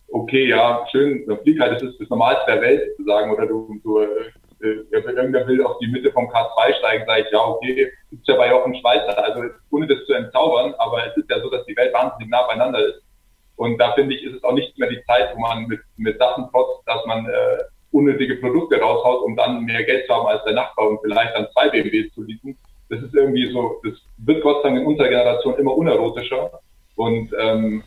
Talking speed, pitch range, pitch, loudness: 225 wpm, 115-155 Hz, 125 Hz, -19 LUFS